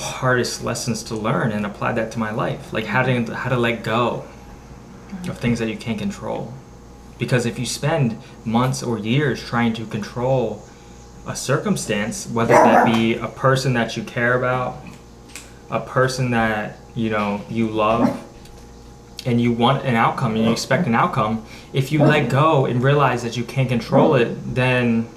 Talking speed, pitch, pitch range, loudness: 175 wpm, 120 Hz, 115-130 Hz, -20 LUFS